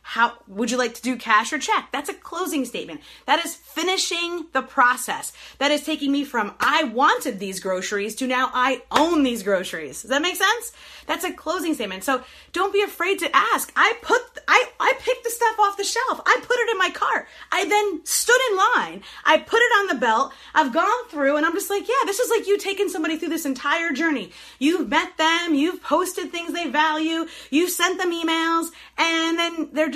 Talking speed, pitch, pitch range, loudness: 220 wpm, 325 Hz, 280-380 Hz, -21 LUFS